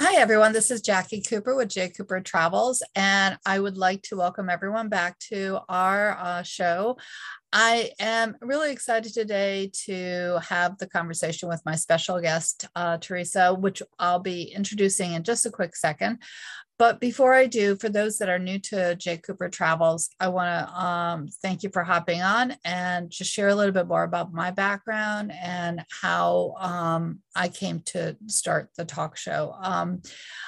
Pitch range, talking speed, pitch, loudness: 175-215 Hz, 175 wpm, 185 Hz, -25 LUFS